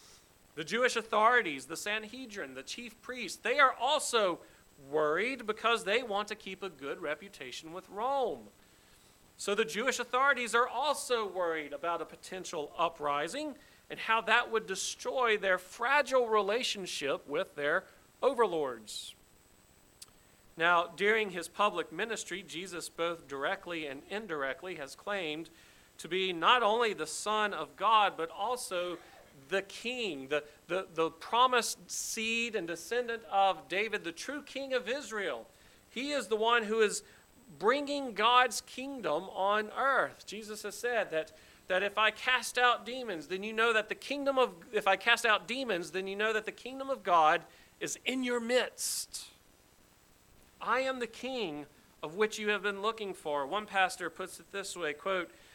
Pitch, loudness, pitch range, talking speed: 205 Hz, -32 LUFS, 170-235 Hz, 155 wpm